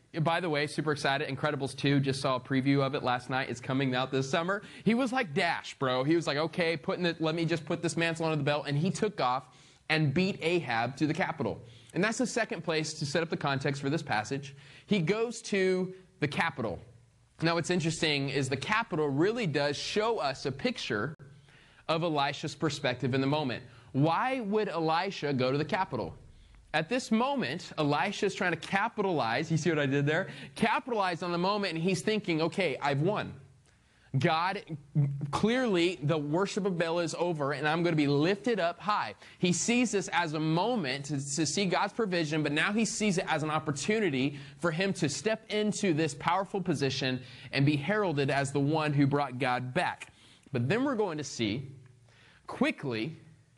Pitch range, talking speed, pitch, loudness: 140-185 Hz, 200 wpm, 160 Hz, -30 LUFS